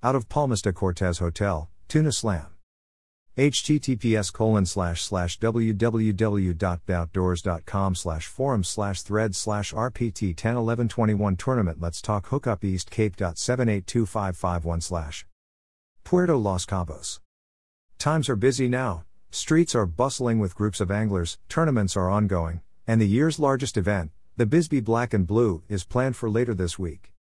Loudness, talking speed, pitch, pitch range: -25 LUFS, 125 wpm, 100 Hz, 90-120 Hz